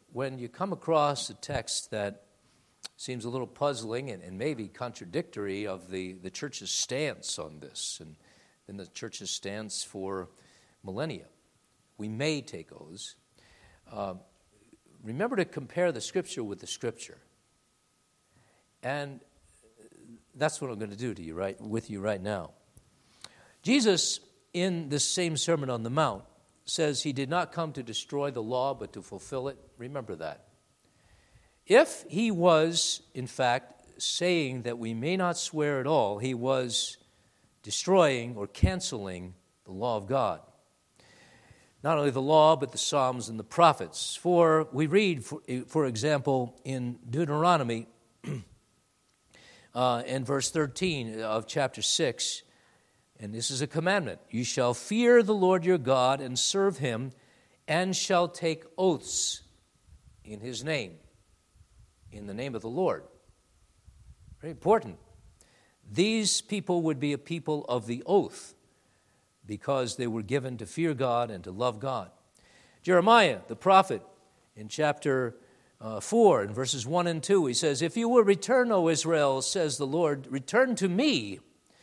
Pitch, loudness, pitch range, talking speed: 130 Hz, -28 LUFS, 115-165 Hz, 145 wpm